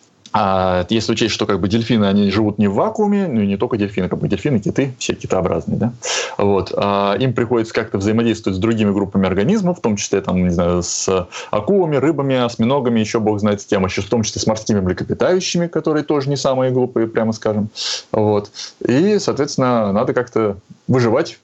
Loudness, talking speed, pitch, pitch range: -17 LUFS, 195 wpm, 110 Hz, 100-130 Hz